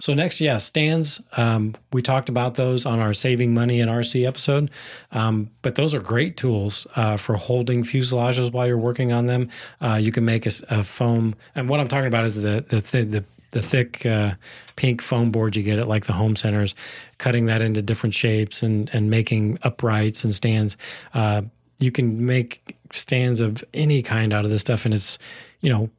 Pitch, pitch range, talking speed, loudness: 115 Hz, 110-125 Hz, 200 wpm, -22 LUFS